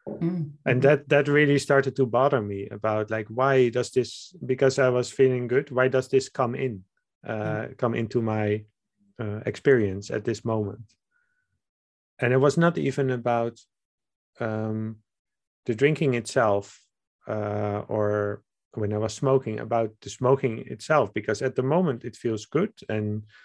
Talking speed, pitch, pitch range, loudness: 155 wpm, 120 Hz, 110-135 Hz, -25 LUFS